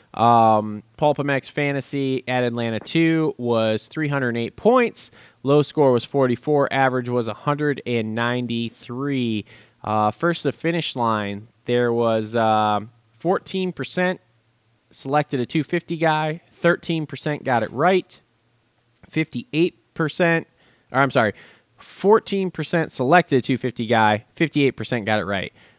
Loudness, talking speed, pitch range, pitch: -21 LUFS, 110 wpm, 115-155 Hz, 130 Hz